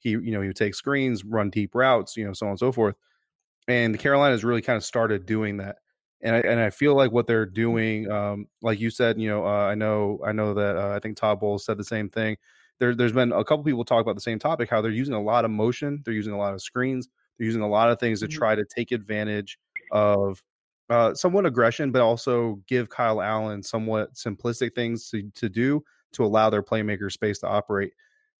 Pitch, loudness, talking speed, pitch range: 110 Hz, -25 LUFS, 240 wpm, 105-120 Hz